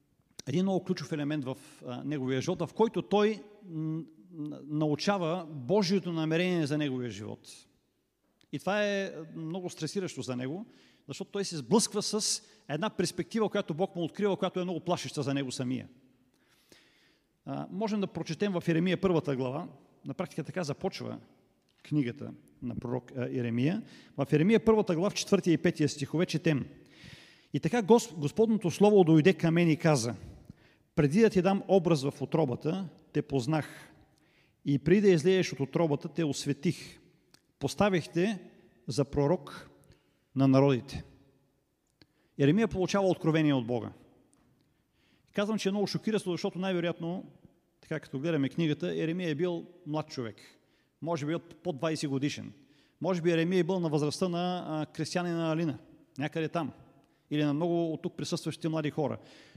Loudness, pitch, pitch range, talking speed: -30 LUFS, 165 Hz, 145-185 Hz, 150 wpm